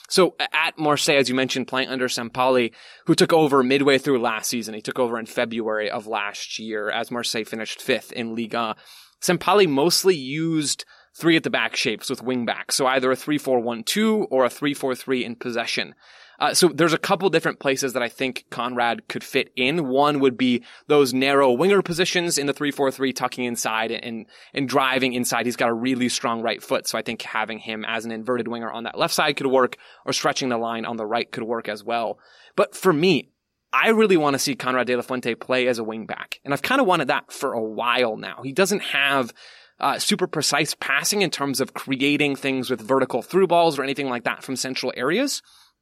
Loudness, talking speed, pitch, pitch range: -22 LUFS, 215 wpm, 130 Hz, 120-145 Hz